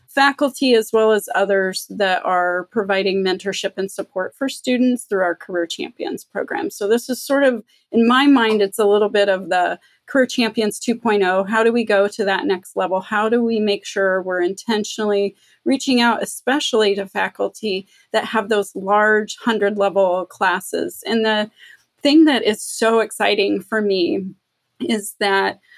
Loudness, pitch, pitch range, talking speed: -18 LUFS, 210 Hz, 195-230 Hz, 170 wpm